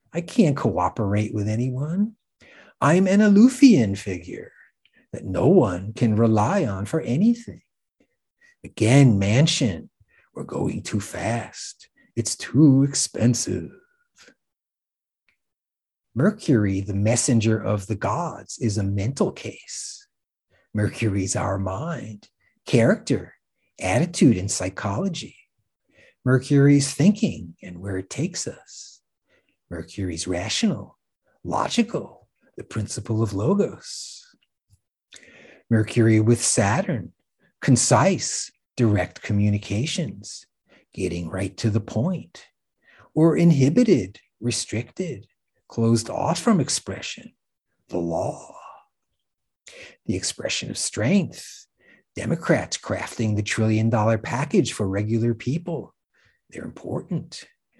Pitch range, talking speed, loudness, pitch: 105-155 Hz, 95 wpm, -22 LUFS, 115 Hz